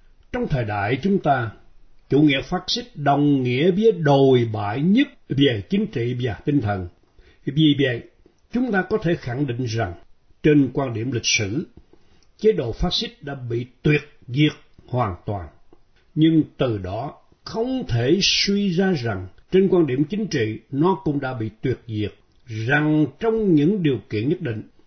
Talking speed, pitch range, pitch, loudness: 170 wpm, 120-180 Hz, 145 Hz, -21 LUFS